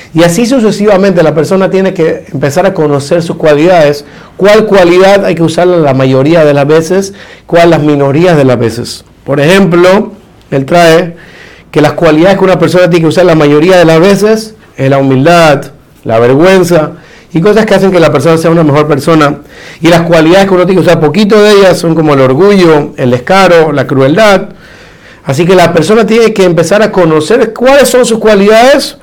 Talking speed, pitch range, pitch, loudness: 195 wpm, 150-195 Hz, 170 Hz, -5 LUFS